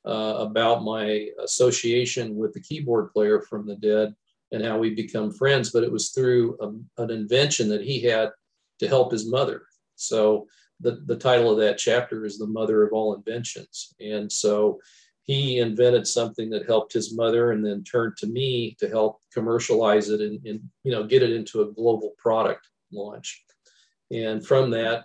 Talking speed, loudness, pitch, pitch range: 180 wpm, -24 LUFS, 110 Hz, 105-120 Hz